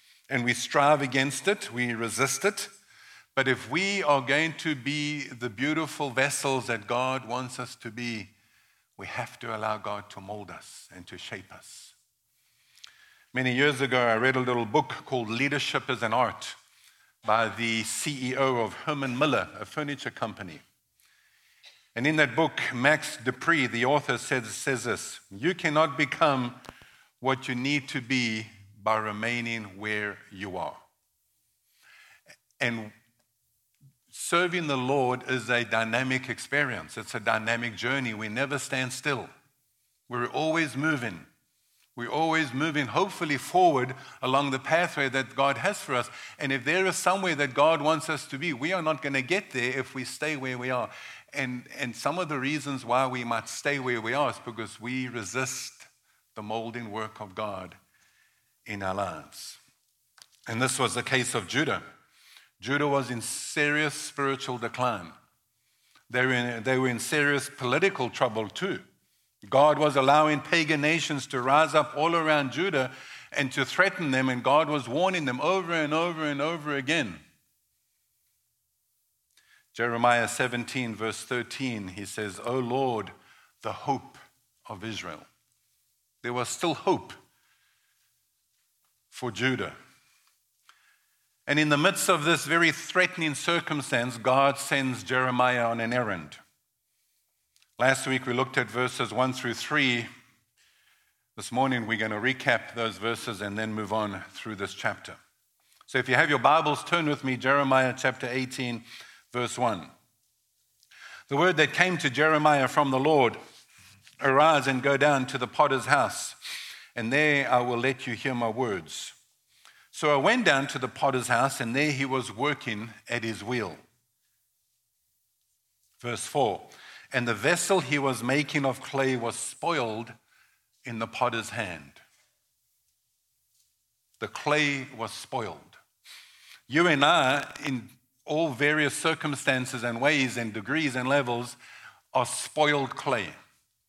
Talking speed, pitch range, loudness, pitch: 150 wpm, 120-145 Hz, -27 LUFS, 130 Hz